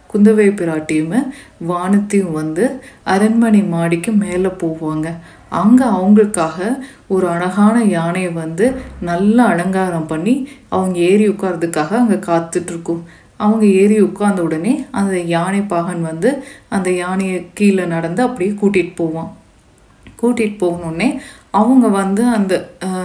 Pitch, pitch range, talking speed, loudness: 190 Hz, 170-215 Hz, 110 wpm, -15 LUFS